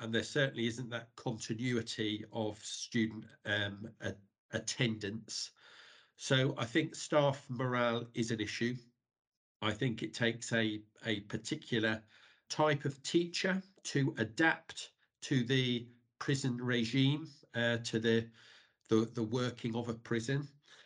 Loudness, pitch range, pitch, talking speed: -36 LUFS, 110-135 Hz, 120 Hz, 125 wpm